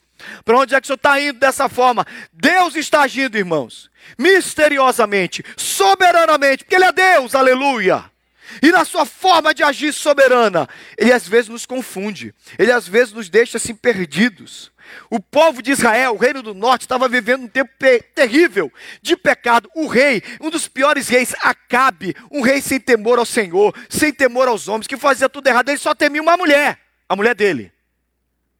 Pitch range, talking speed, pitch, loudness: 235-300 Hz, 180 wpm, 265 Hz, -15 LUFS